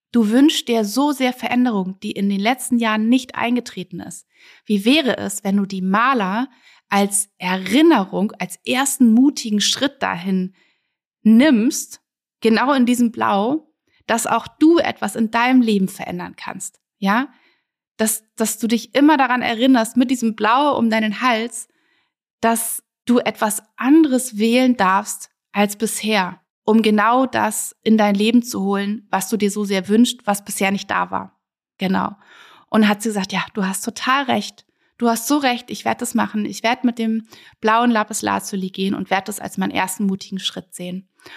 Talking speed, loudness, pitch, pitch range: 170 wpm, -18 LUFS, 225 Hz, 200-250 Hz